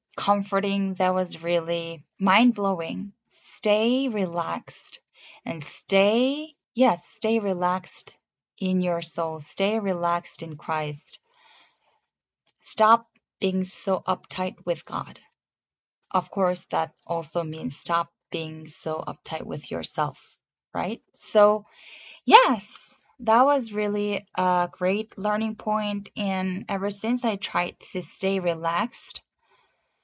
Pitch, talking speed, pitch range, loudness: 190 Hz, 110 wpm, 170-210 Hz, -25 LUFS